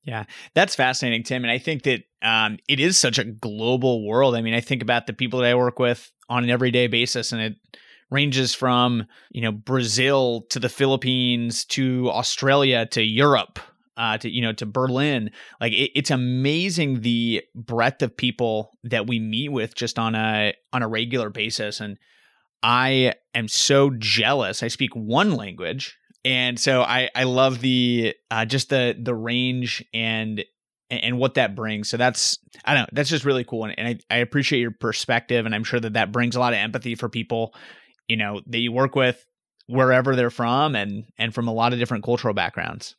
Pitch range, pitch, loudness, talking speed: 115-130 Hz, 120 Hz, -22 LUFS, 195 wpm